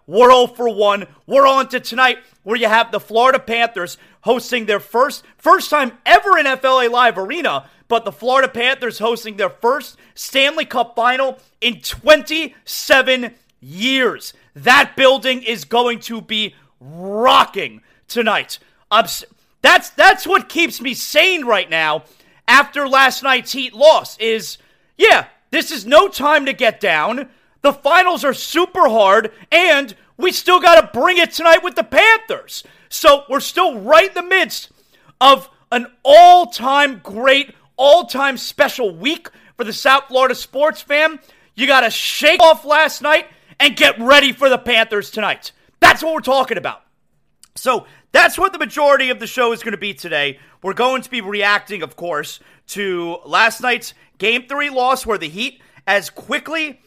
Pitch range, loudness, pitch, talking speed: 225-300 Hz, -14 LUFS, 260 Hz, 160 wpm